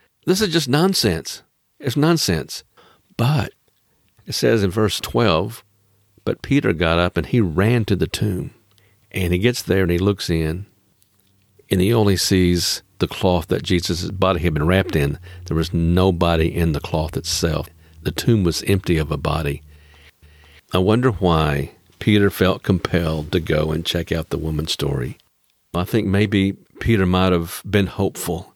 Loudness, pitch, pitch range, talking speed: -20 LUFS, 95 Hz, 85-105 Hz, 165 wpm